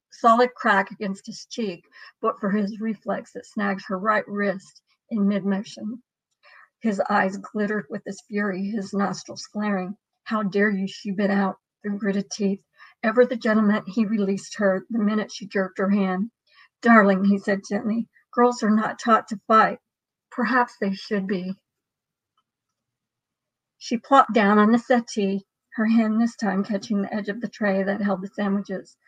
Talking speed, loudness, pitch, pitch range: 165 wpm, -23 LUFS, 205 Hz, 195-220 Hz